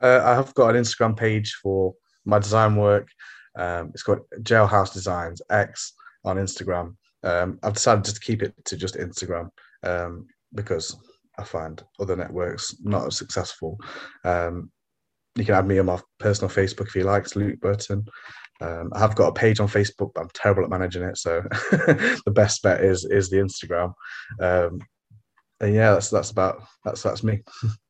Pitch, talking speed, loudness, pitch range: 100 Hz, 180 wpm, -23 LUFS, 90-105 Hz